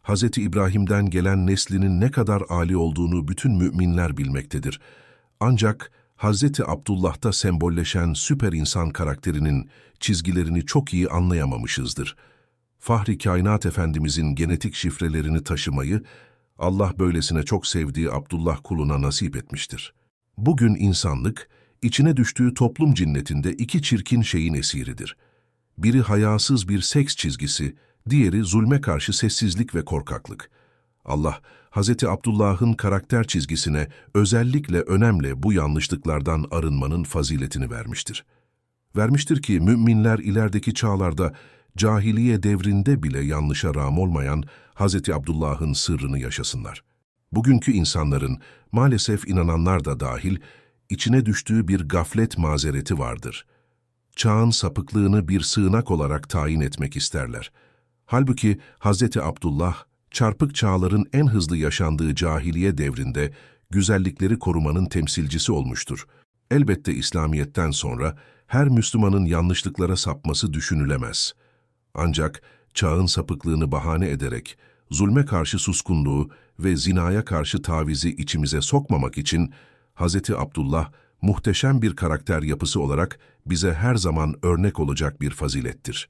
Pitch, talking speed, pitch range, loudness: 95 Hz, 110 wpm, 80-110 Hz, -22 LUFS